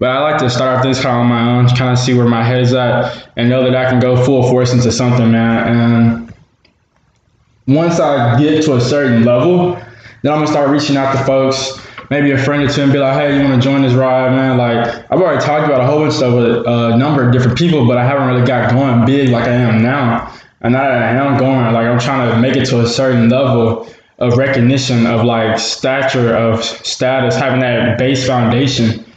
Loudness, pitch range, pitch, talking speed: -12 LUFS, 120-135 Hz, 125 Hz, 240 wpm